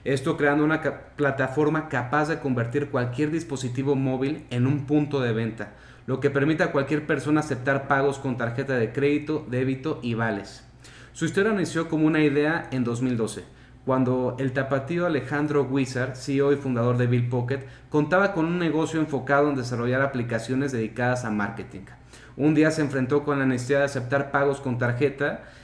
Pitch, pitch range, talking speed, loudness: 140 Hz, 125-150 Hz, 170 wpm, -25 LUFS